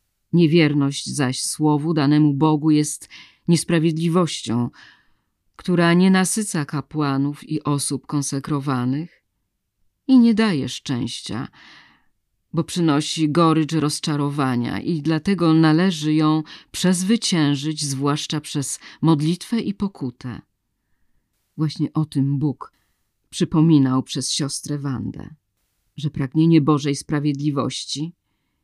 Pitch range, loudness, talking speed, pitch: 135-160 Hz, -20 LUFS, 90 wpm, 150 Hz